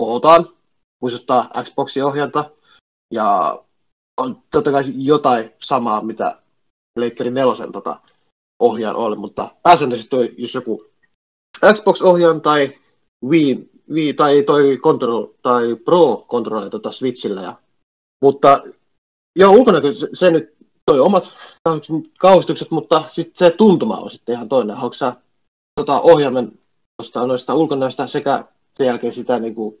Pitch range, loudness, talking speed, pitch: 125-160 Hz, -16 LUFS, 130 wpm, 140 Hz